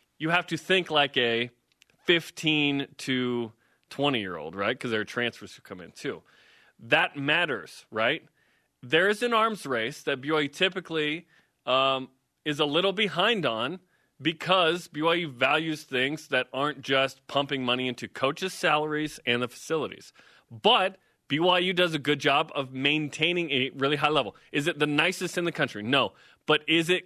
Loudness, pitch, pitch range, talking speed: -26 LUFS, 150 Hz, 130-170 Hz, 165 wpm